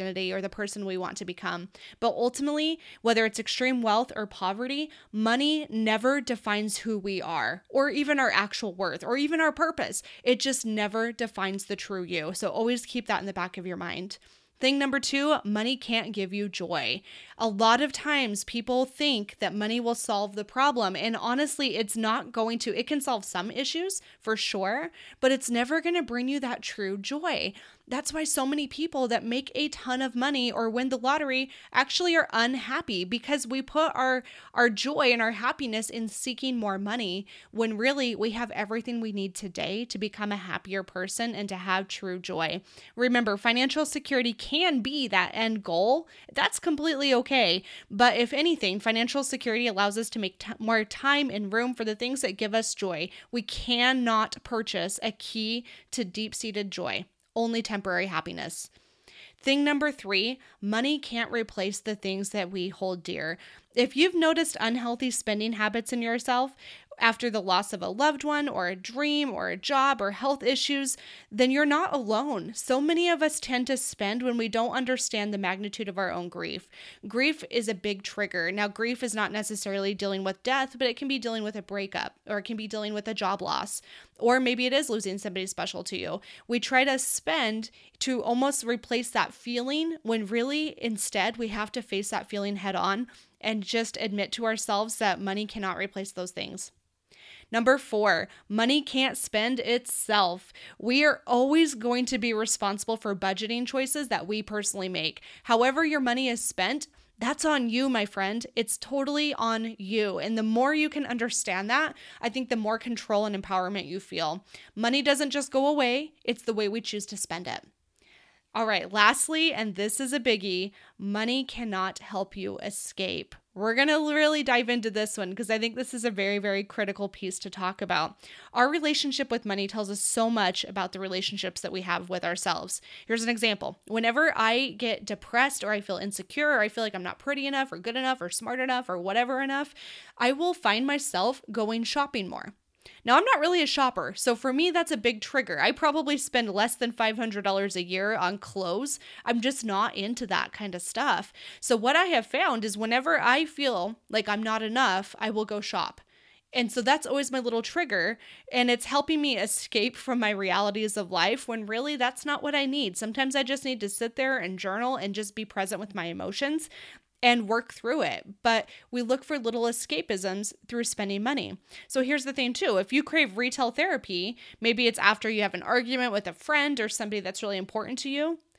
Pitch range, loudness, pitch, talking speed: 205-265 Hz, -28 LUFS, 230 Hz, 195 wpm